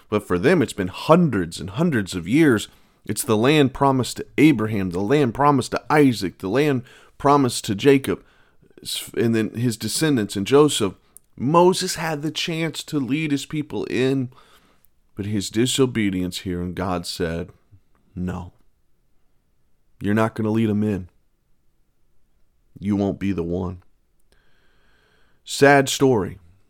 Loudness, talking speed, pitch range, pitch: -21 LUFS, 140 wpm, 95-140 Hz, 110 Hz